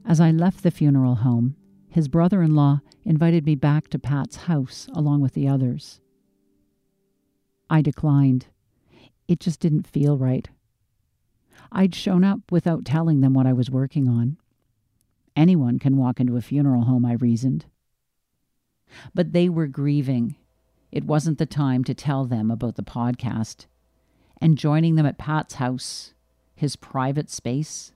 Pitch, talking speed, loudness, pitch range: 140 Hz, 150 wpm, -22 LUFS, 120-155 Hz